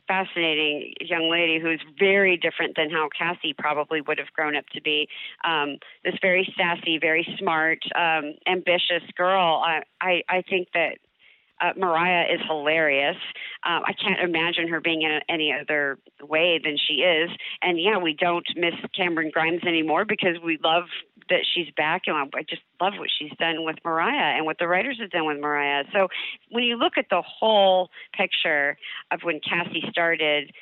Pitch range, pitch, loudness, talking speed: 155-185 Hz, 170 Hz, -23 LUFS, 180 wpm